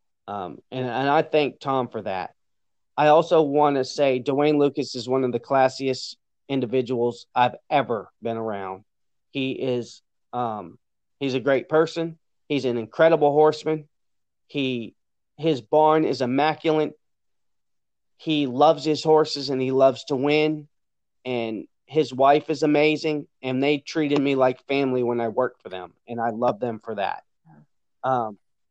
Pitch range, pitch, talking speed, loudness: 120-150 Hz, 135 Hz, 160 wpm, -23 LUFS